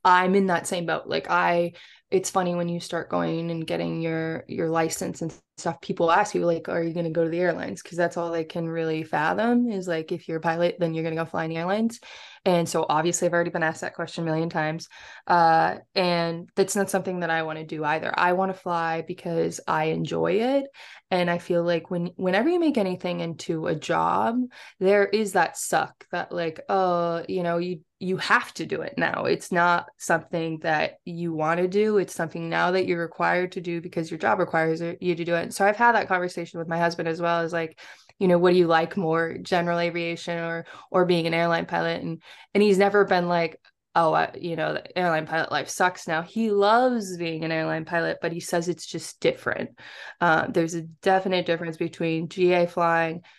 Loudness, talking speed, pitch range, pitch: -25 LUFS, 225 wpm, 165-185 Hz, 170 Hz